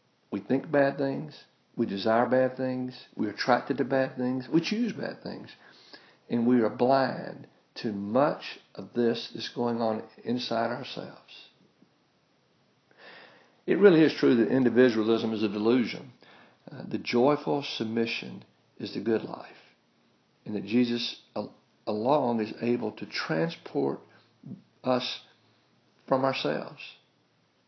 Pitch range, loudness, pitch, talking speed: 115-130 Hz, -28 LUFS, 120 Hz, 130 wpm